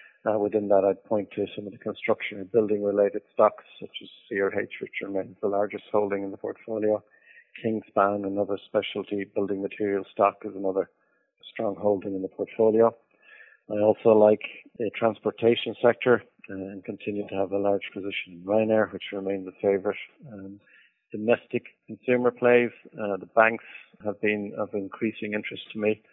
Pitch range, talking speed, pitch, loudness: 100-110 Hz, 170 wpm, 105 Hz, -26 LUFS